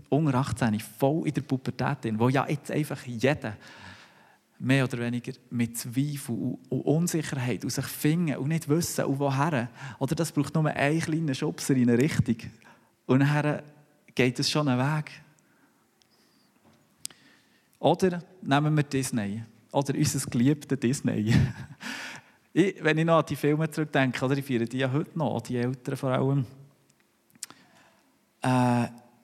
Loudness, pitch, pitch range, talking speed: -27 LUFS, 135 Hz, 125-150 Hz, 150 wpm